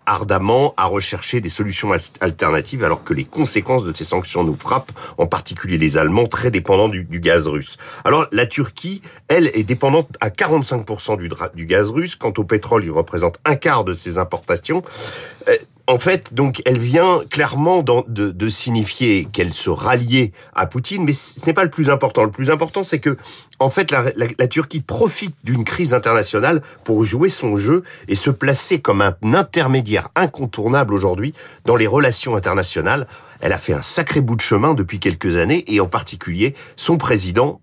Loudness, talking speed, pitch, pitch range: -17 LUFS, 185 wpm, 125 Hz, 110-160 Hz